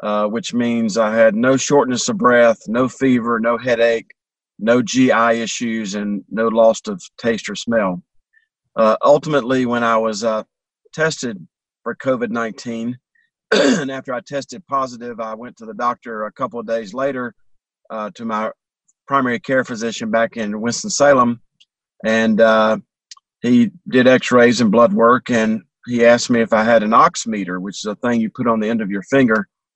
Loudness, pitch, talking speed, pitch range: -17 LUFS, 120 Hz, 170 wpm, 110-130 Hz